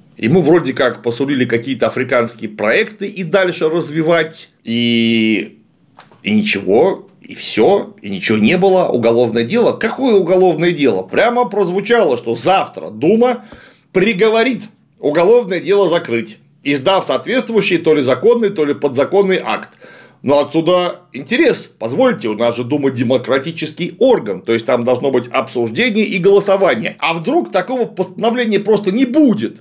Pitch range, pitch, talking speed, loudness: 130-215 Hz, 175 Hz, 135 wpm, -14 LUFS